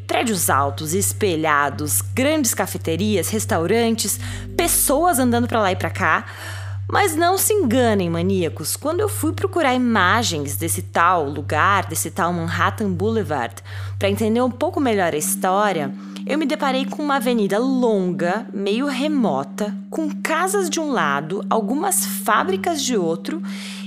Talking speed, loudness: 140 wpm, -20 LUFS